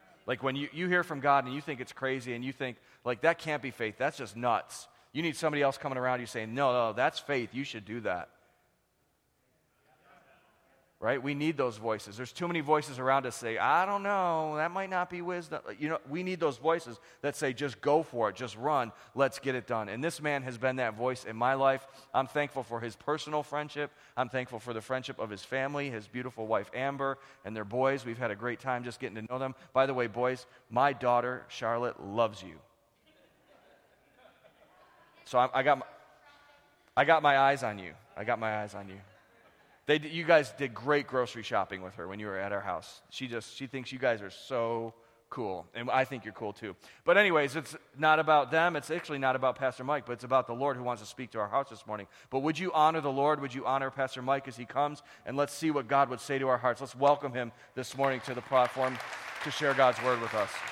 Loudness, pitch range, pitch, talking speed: -31 LUFS, 120-145 Hz, 130 Hz, 235 wpm